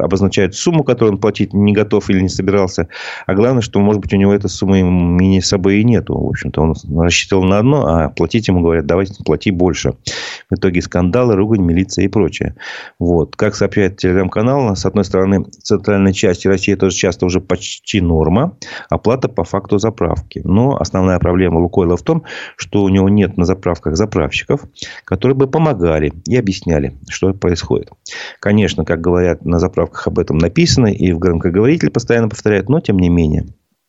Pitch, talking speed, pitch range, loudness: 95 Hz, 180 wpm, 90-105 Hz, -14 LUFS